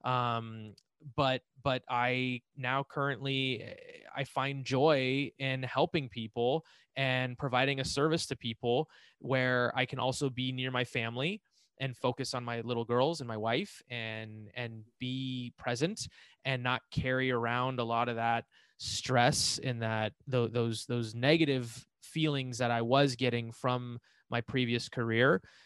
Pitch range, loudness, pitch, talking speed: 120-135 Hz, -33 LUFS, 125 Hz, 145 wpm